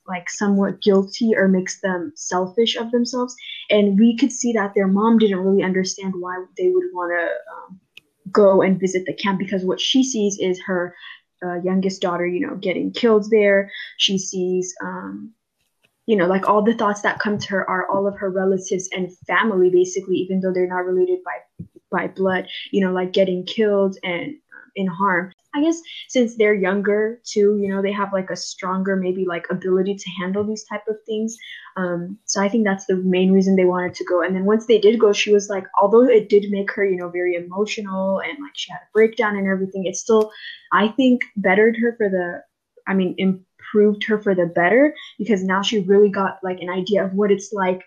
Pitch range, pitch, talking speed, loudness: 185-215 Hz, 195 Hz, 210 wpm, -20 LUFS